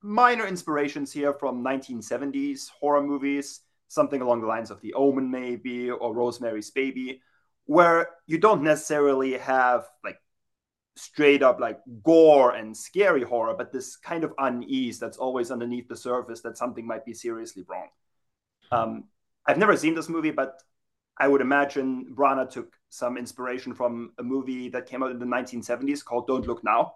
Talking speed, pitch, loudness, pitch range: 165 wpm, 130 Hz, -25 LUFS, 120-145 Hz